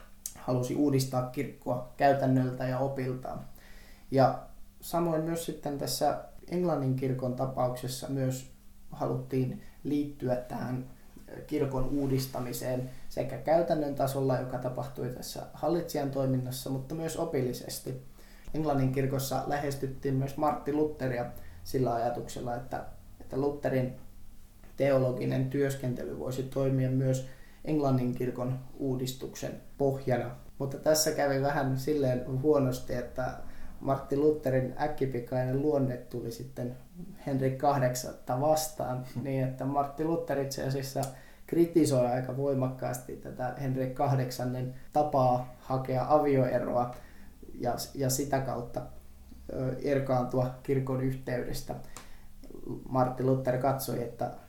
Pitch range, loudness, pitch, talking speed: 125-140 Hz, -31 LUFS, 130 Hz, 100 wpm